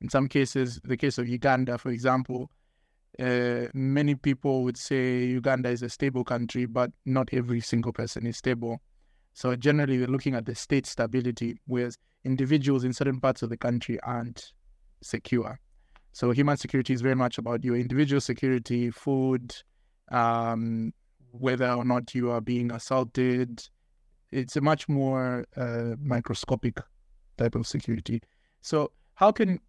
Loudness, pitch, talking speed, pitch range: -28 LUFS, 125 Hz, 150 wpm, 120-135 Hz